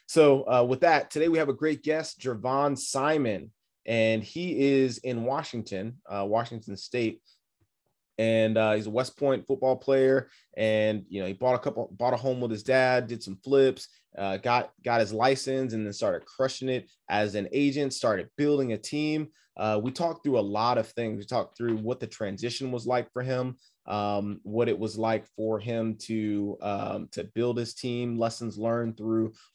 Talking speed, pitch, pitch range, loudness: 195 wpm, 120 Hz, 110-135 Hz, -28 LUFS